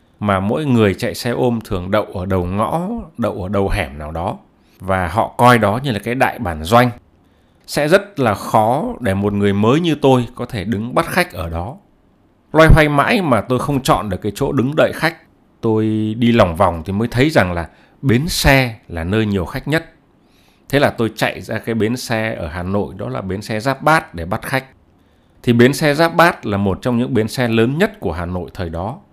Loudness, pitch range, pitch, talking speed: -17 LUFS, 95-130 Hz, 110 Hz, 230 wpm